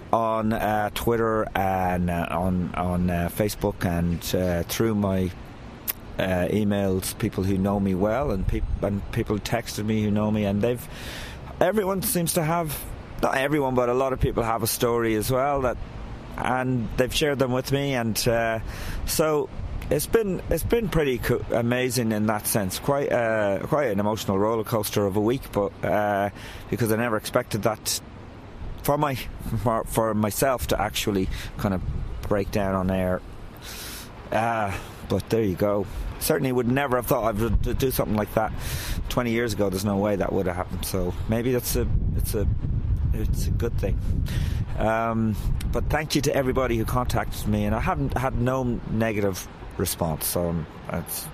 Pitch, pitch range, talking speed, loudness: 110 Hz, 100-120 Hz, 180 wpm, -25 LUFS